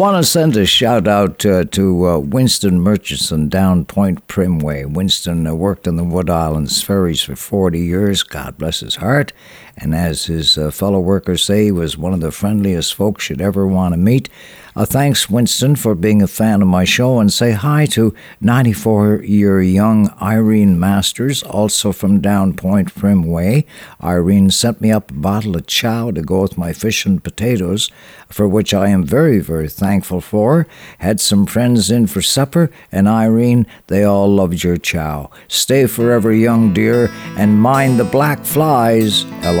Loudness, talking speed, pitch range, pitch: -14 LUFS, 180 wpm, 90-110 Hz, 100 Hz